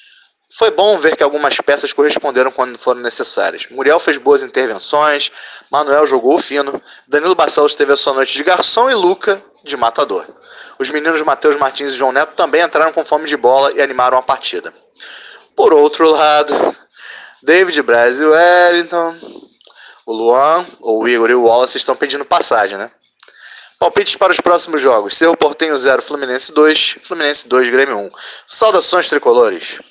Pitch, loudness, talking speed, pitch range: 150 Hz, -12 LUFS, 160 wpm, 135-195 Hz